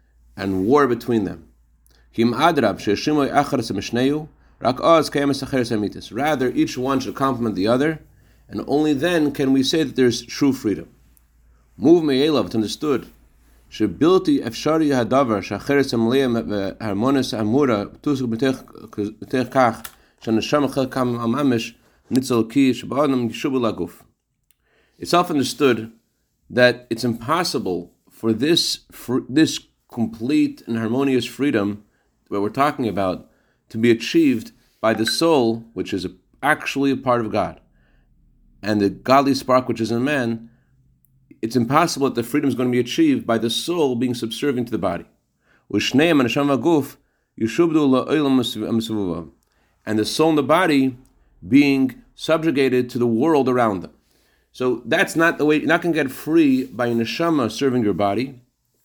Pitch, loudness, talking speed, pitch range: 125 Hz, -20 LUFS, 110 wpm, 110-140 Hz